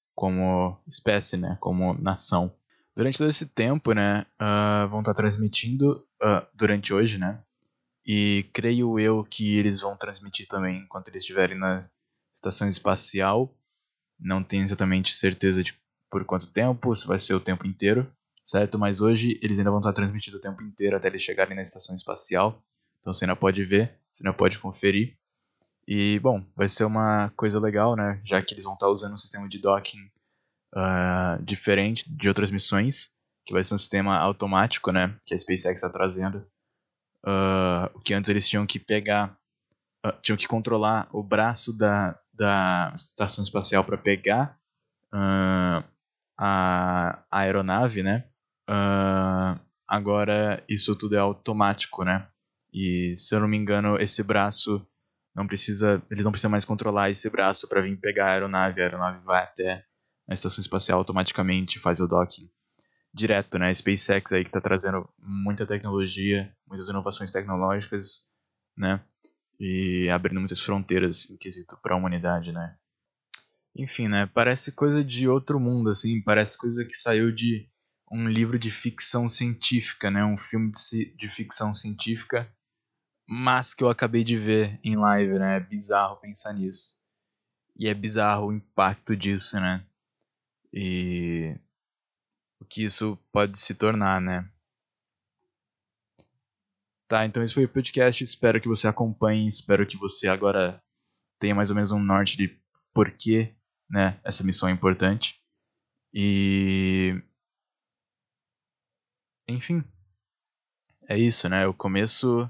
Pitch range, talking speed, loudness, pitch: 95-110 Hz, 150 wpm, -25 LUFS, 100 Hz